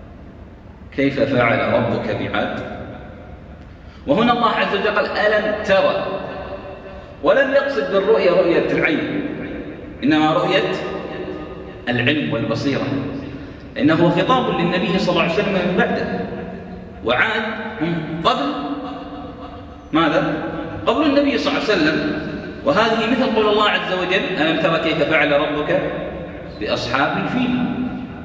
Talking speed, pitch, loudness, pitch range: 110 wpm, 190 Hz, -18 LUFS, 140-230 Hz